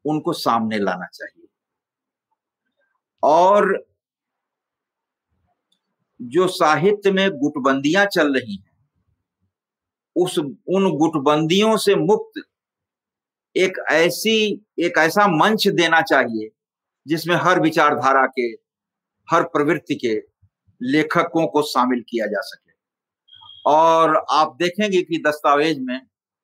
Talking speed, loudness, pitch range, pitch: 100 wpm, -18 LUFS, 145-200 Hz, 165 Hz